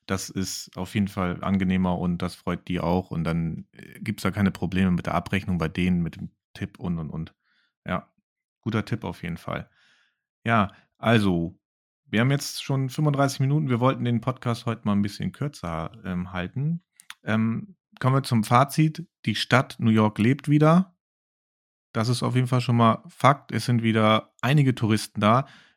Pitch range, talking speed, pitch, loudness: 95-130 Hz, 185 wpm, 110 Hz, -25 LUFS